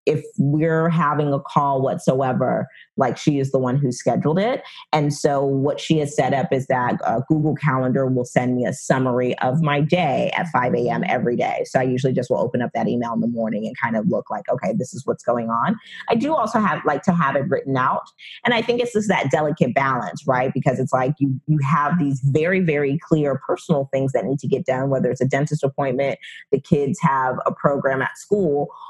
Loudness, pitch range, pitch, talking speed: -21 LUFS, 130-155 Hz, 140 Hz, 230 wpm